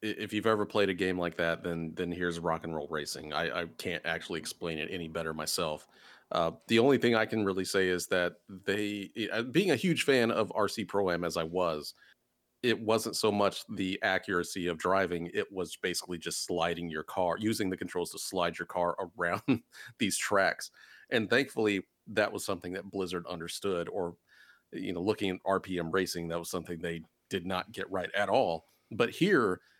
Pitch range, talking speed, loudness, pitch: 85-105 Hz, 195 wpm, -32 LUFS, 95 Hz